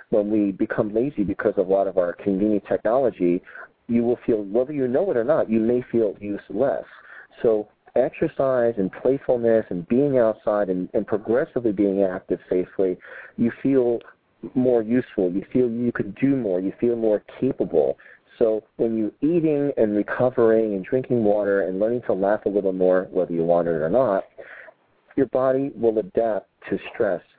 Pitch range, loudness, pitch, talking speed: 100-125 Hz, -22 LUFS, 110 Hz, 175 wpm